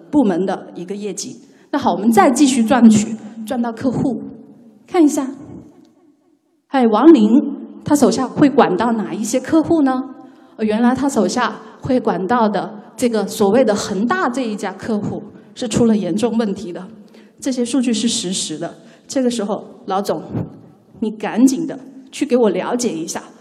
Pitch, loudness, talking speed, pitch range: 235 Hz, -17 LUFS, 235 characters per minute, 210-270 Hz